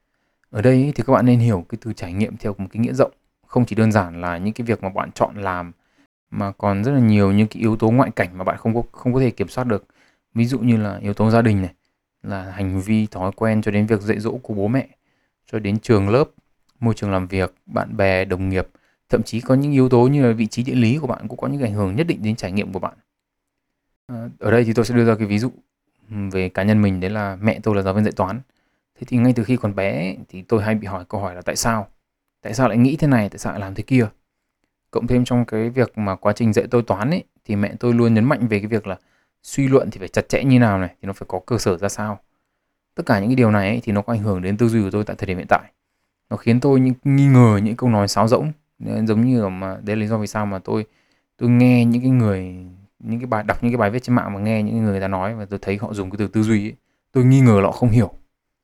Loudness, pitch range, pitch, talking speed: -19 LUFS, 100-120 Hz, 110 Hz, 290 wpm